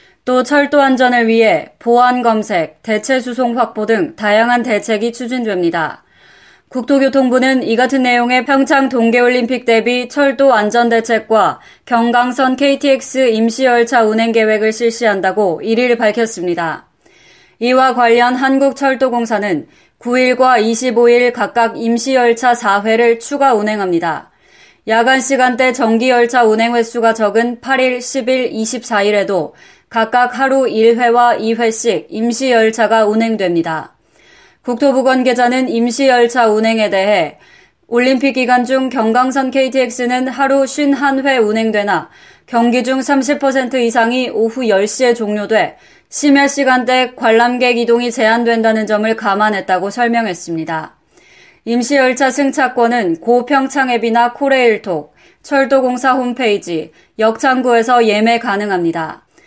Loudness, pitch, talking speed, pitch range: -13 LUFS, 240 Hz, 270 characters per minute, 225-260 Hz